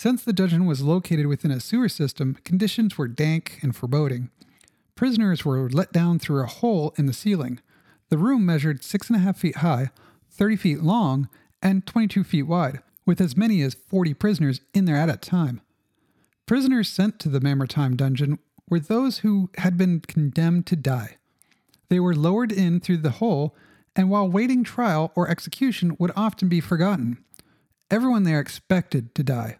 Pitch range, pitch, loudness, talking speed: 145-200 Hz, 170 Hz, -23 LUFS, 175 wpm